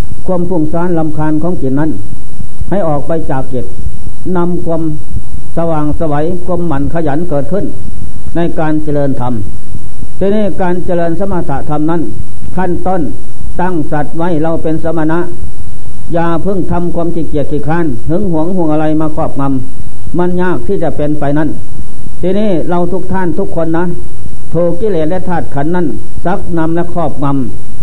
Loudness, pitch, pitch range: -15 LUFS, 160 Hz, 145-175 Hz